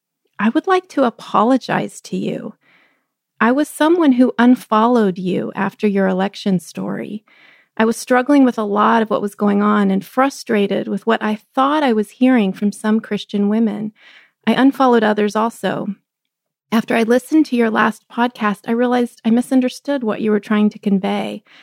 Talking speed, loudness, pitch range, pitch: 170 wpm, -17 LUFS, 205-250 Hz, 220 Hz